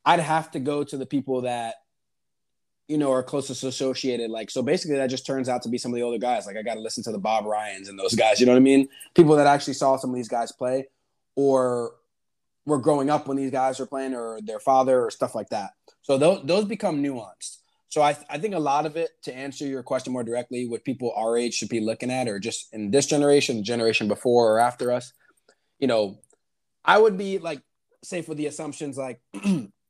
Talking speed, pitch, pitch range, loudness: 235 wpm, 130 Hz, 120-145 Hz, -24 LUFS